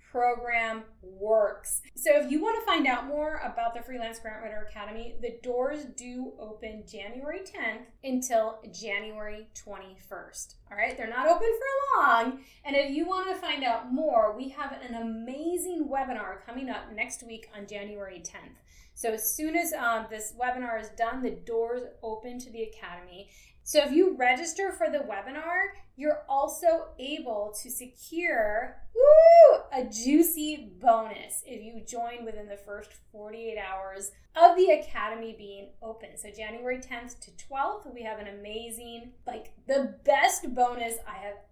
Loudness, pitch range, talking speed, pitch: -27 LUFS, 220-295 Hz, 160 wpm, 240 Hz